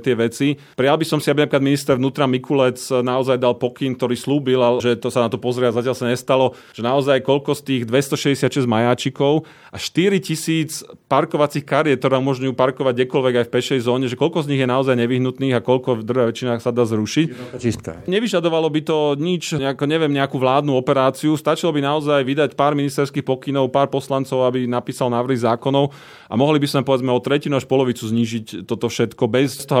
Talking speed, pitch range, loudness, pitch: 195 wpm, 125-145 Hz, -19 LUFS, 135 Hz